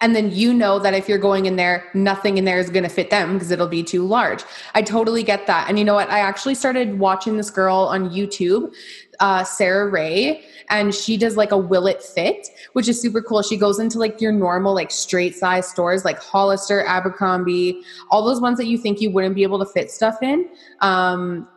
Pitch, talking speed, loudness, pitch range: 200 Hz, 230 wpm, -19 LUFS, 185-220 Hz